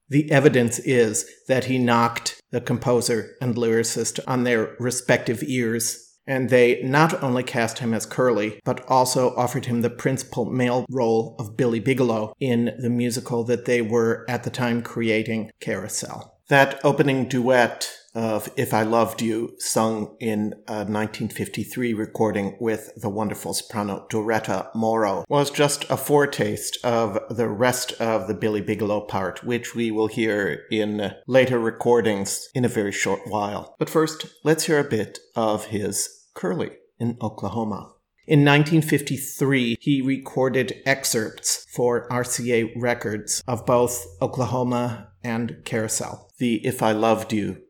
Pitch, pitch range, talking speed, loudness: 120 Hz, 110-130 Hz, 145 wpm, -23 LUFS